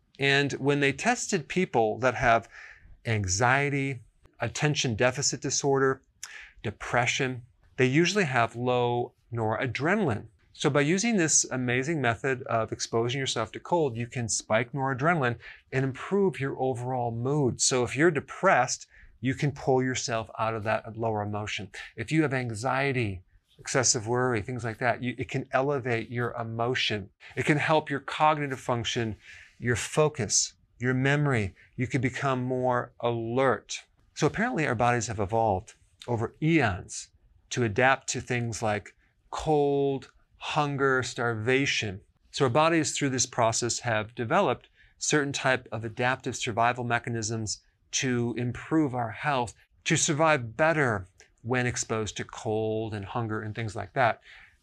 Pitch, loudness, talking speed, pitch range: 125 Hz, -27 LUFS, 140 wpm, 115-140 Hz